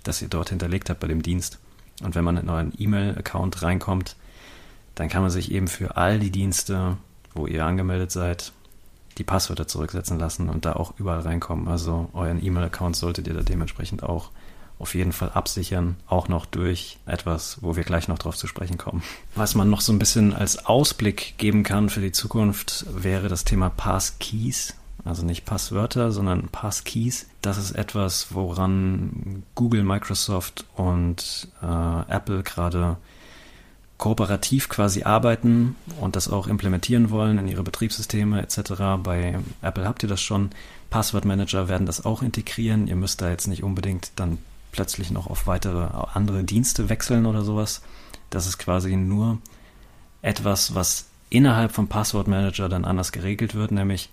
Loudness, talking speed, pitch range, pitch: -24 LUFS, 160 wpm, 90-105 Hz, 95 Hz